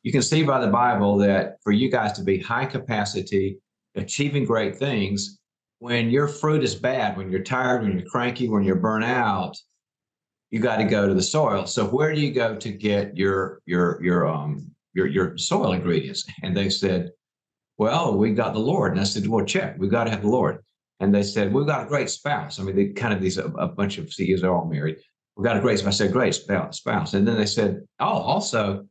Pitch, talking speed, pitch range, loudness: 100 Hz, 230 wpm, 95-120 Hz, -23 LUFS